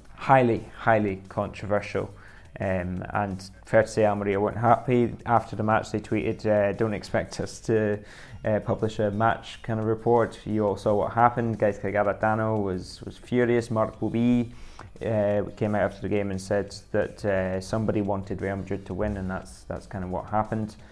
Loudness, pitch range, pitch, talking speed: -26 LUFS, 100-110 Hz, 105 Hz, 180 wpm